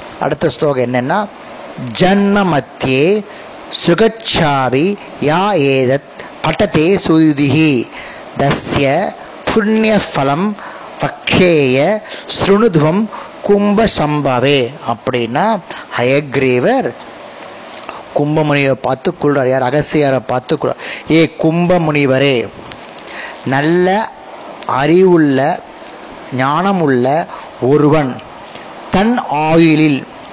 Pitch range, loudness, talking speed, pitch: 135-195 Hz, -13 LUFS, 60 wpm, 155 Hz